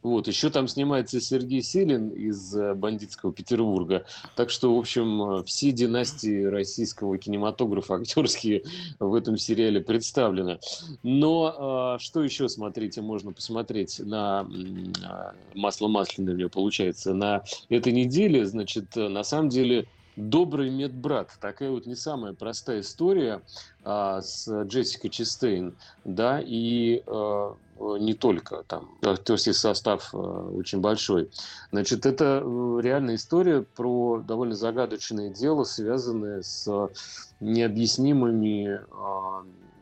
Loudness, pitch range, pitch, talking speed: -27 LUFS, 100-125 Hz, 110 Hz, 115 wpm